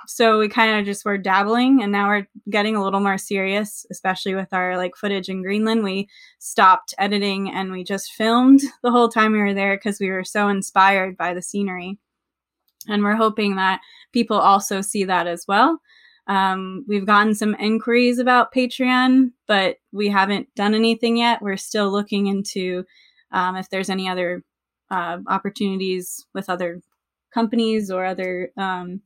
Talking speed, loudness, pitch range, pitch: 170 wpm, -20 LUFS, 190-220 Hz, 200 Hz